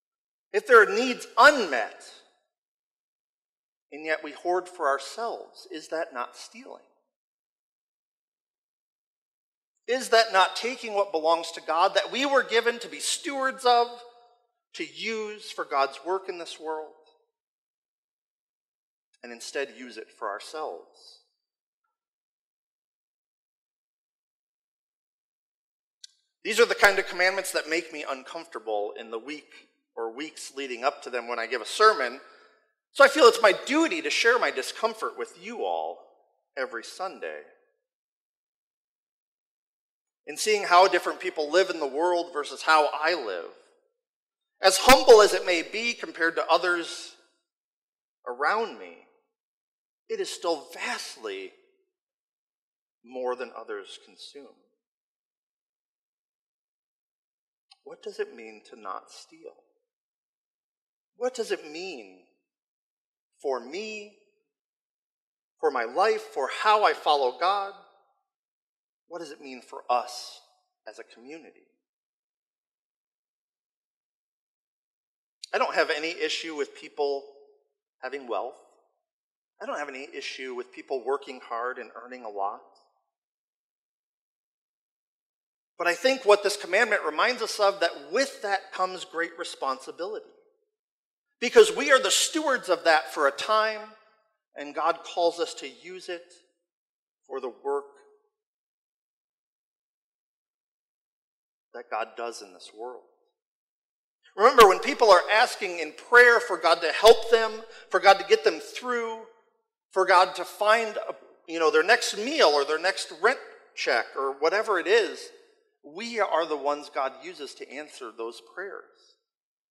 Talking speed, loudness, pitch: 130 wpm, -24 LUFS, 235 Hz